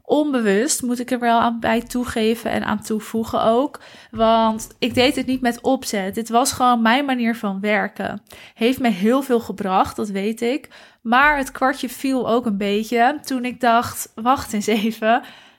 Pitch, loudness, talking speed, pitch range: 235 Hz, -20 LUFS, 180 wpm, 225-255 Hz